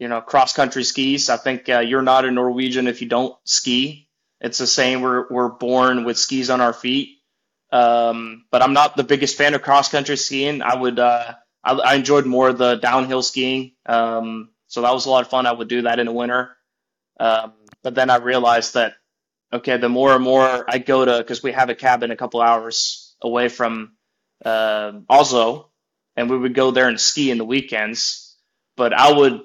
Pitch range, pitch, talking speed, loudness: 120-130 Hz, 125 Hz, 210 wpm, -18 LUFS